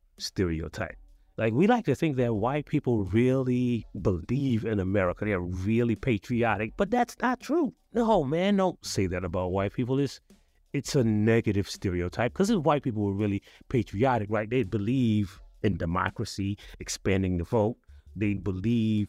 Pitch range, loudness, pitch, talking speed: 100-130 Hz, -28 LUFS, 110 Hz, 155 wpm